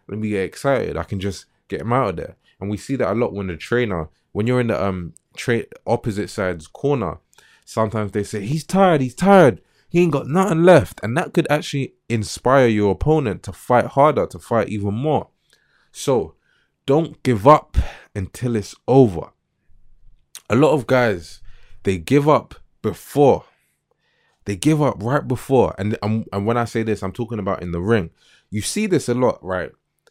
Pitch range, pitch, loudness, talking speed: 100-140 Hz, 115 Hz, -19 LUFS, 190 wpm